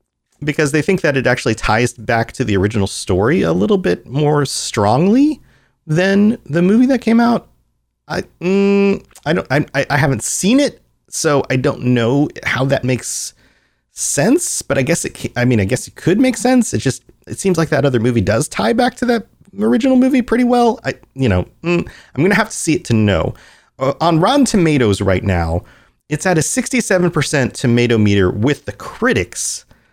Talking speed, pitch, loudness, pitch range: 190 wpm, 145 Hz, -15 LUFS, 120-195 Hz